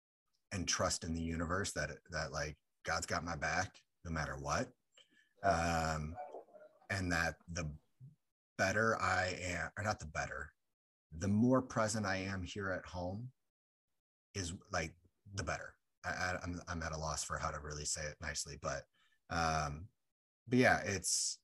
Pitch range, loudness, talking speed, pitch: 80-100 Hz, -38 LUFS, 160 wpm, 85 Hz